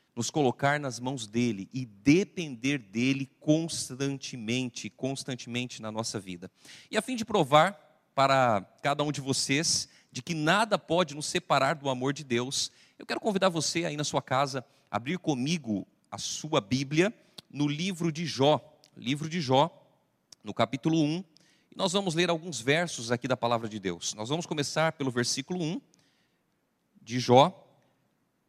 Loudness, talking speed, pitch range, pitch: -29 LUFS, 160 wpm, 125-160 Hz, 140 Hz